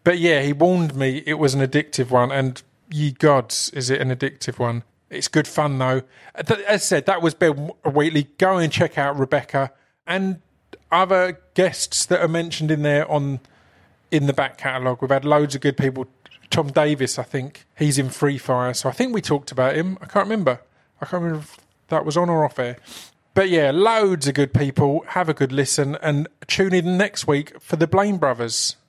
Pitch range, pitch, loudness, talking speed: 135-170 Hz, 145 Hz, -20 LUFS, 210 wpm